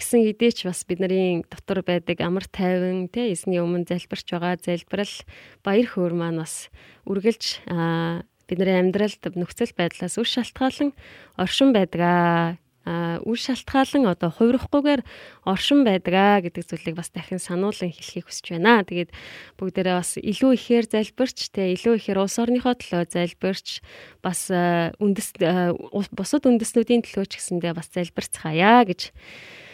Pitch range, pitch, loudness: 175-230 Hz, 185 Hz, -23 LUFS